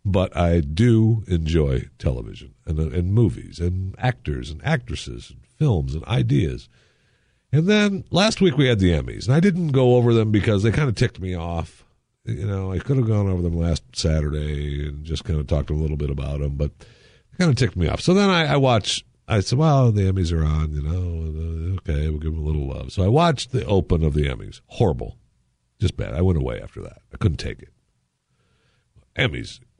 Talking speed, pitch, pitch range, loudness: 215 wpm, 95 Hz, 75-125 Hz, -22 LUFS